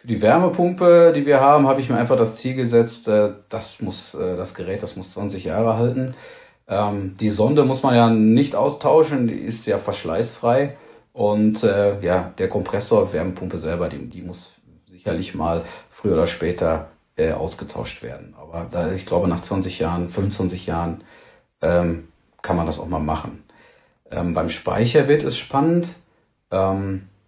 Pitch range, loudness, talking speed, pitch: 90-130 Hz, -20 LUFS, 150 wpm, 105 Hz